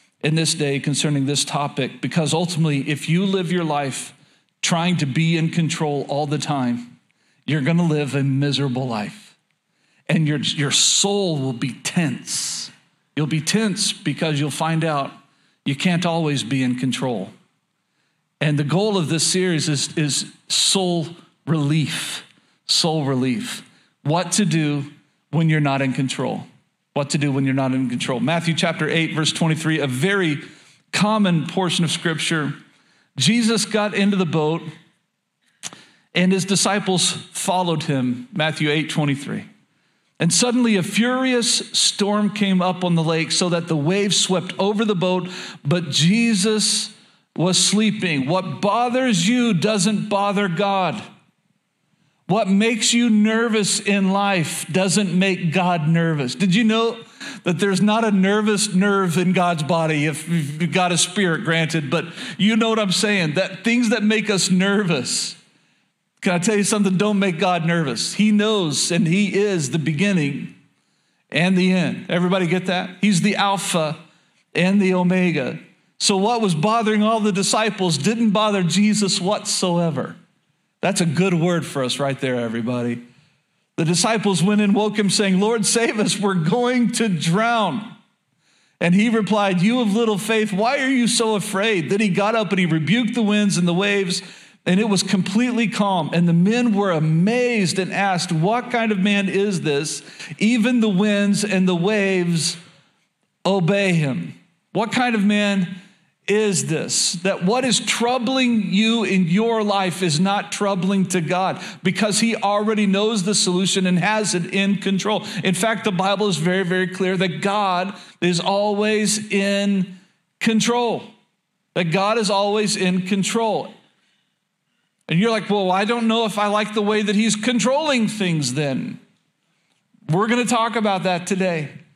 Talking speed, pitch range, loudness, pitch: 160 wpm, 165-210 Hz, -19 LUFS, 190 Hz